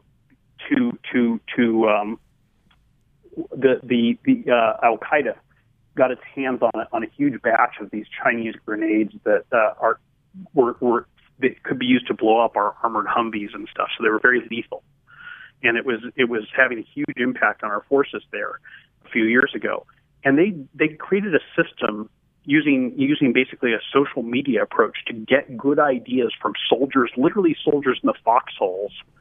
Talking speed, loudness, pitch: 175 wpm, -21 LUFS, 140 Hz